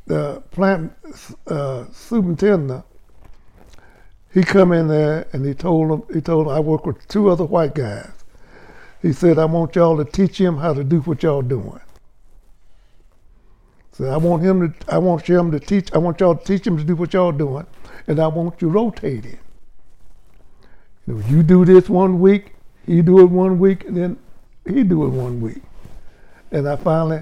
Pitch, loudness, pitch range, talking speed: 165 Hz, -17 LUFS, 140-180 Hz, 185 wpm